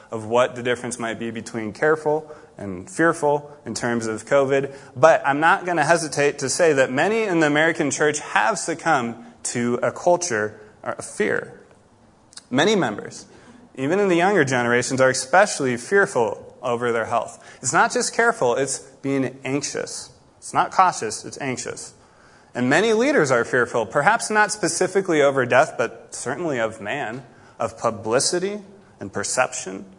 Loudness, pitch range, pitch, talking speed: -21 LUFS, 120-175 Hz, 145 Hz, 155 wpm